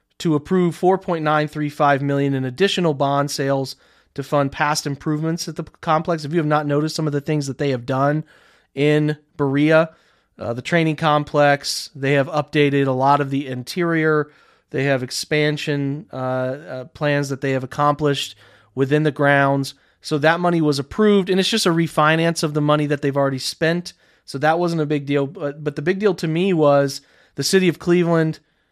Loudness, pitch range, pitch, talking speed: -19 LUFS, 140-160 Hz, 150 Hz, 190 wpm